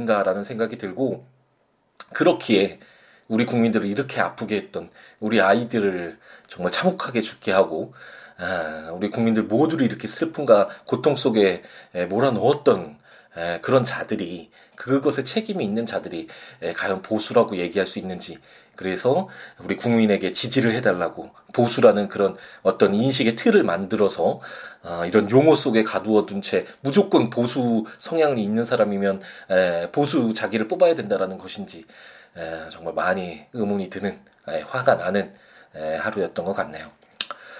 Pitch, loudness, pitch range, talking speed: 110 Hz, -22 LUFS, 95-125 Hz, 310 characters per minute